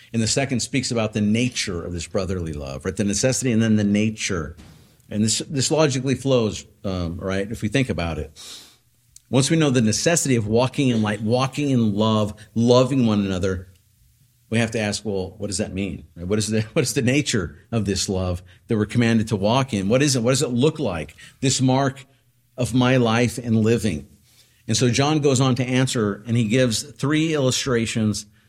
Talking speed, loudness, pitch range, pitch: 205 wpm, -21 LUFS, 105-130 Hz, 115 Hz